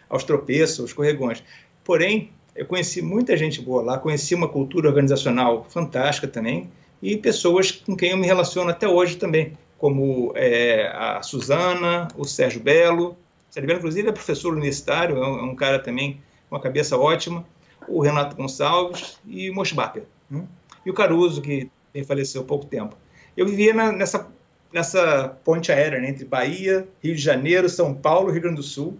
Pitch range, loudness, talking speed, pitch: 140-180 Hz, -21 LUFS, 180 wpm, 160 Hz